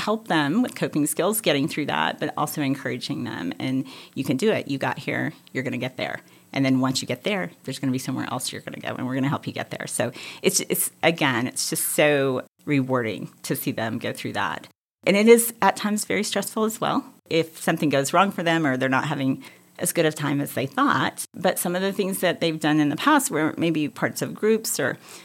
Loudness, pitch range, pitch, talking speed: -24 LUFS, 135-200 Hz, 155 Hz, 240 wpm